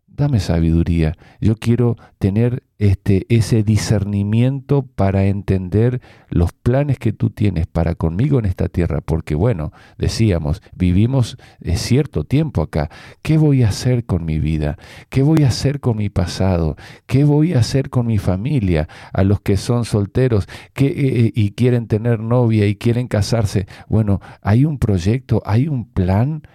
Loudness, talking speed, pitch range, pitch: -18 LUFS, 160 wpm, 95-125 Hz, 110 Hz